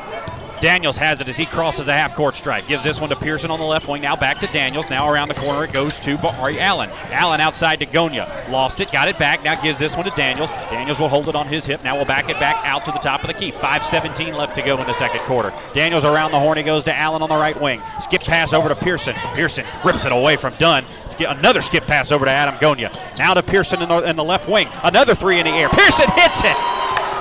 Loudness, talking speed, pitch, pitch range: -17 LUFS, 265 wpm, 155 Hz, 145-160 Hz